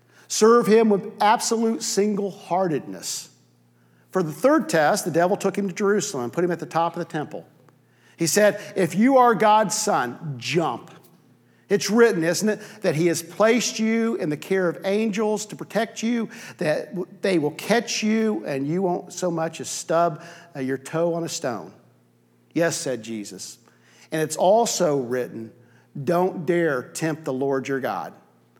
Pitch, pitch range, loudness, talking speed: 175 Hz, 145-210 Hz, -22 LUFS, 170 wpm